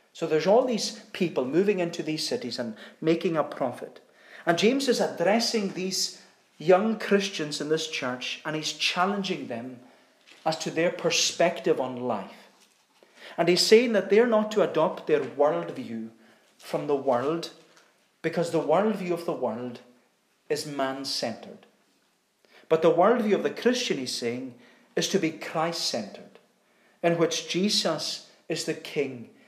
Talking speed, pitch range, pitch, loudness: 150 wpm, 150-200 Hz, 170 Hz, -26 LUFS